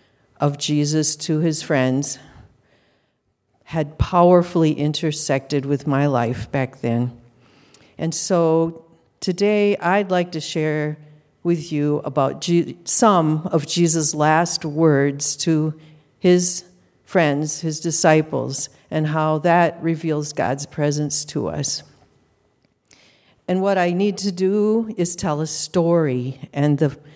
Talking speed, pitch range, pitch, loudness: 115 wpm, 140-170 Hz, 155 Hz, -20 LUFS